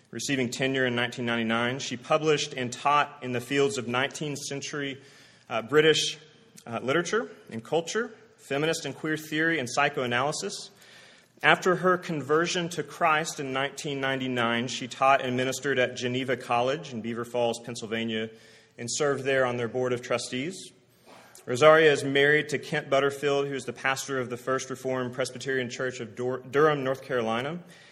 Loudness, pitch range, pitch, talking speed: -27 LUFS, 125-150 Hz, 135 Hz, 155 wpm